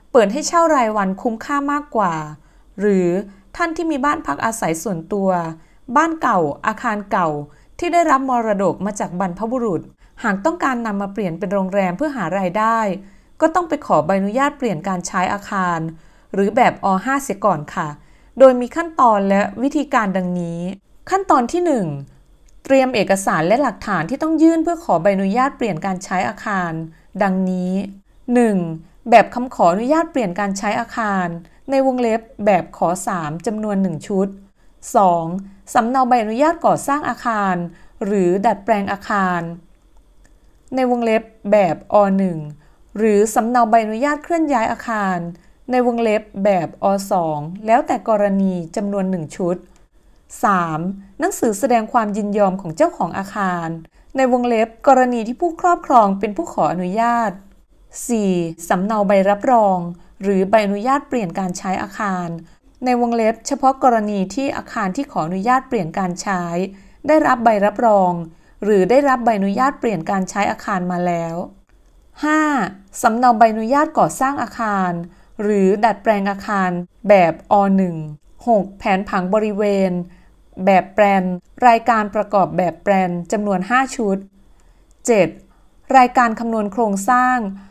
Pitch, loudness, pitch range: 210 Hz, -18 LUFS, 185-245 Hz